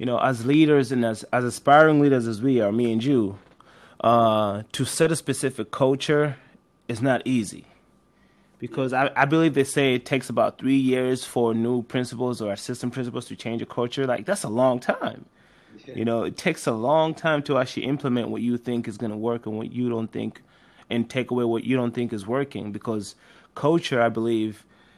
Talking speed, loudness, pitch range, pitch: 205 wpm, -23 LUFS, 115-135 Hz, 125 Hz